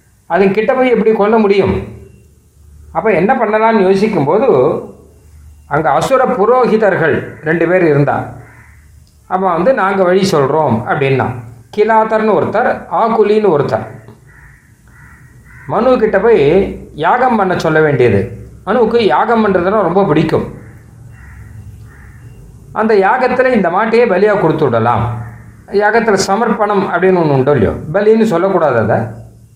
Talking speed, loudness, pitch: 110 wpm, -12 LUFS, 165 Hz